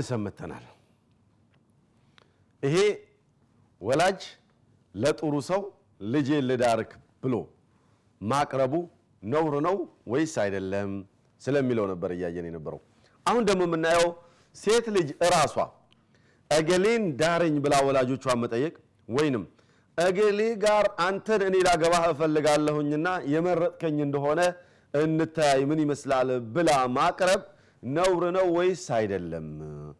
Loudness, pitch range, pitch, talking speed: -26 LUFS, 120-175 Hz, 150 Hz, 90 wpm